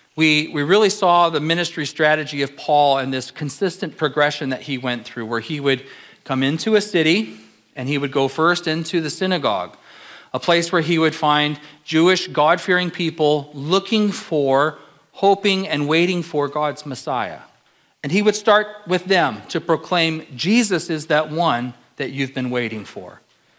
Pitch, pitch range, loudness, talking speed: 155 Hz, 140-175 Hz, -19 LUFS, 170 wpm